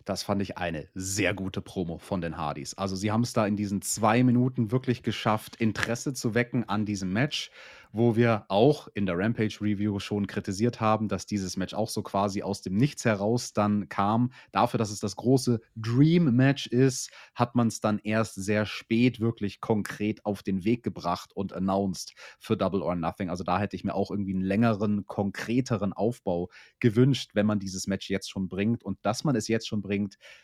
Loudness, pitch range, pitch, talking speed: -28 LUFS, 100-115 Hz, 105 Hz, 200 wpm